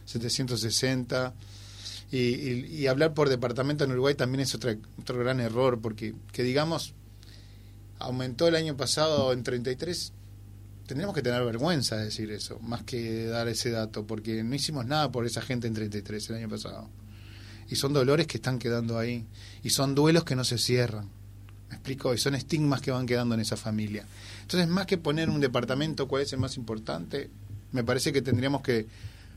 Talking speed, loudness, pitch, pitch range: 180 wpm, -29 LUFS, 120 Hz, 105-135 Hz